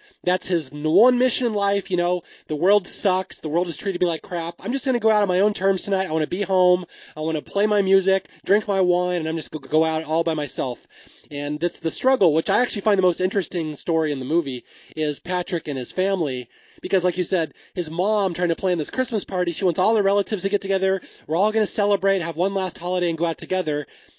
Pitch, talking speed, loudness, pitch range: 180 Hz, 255 wpm, -22 LUFS, 165-200 Hz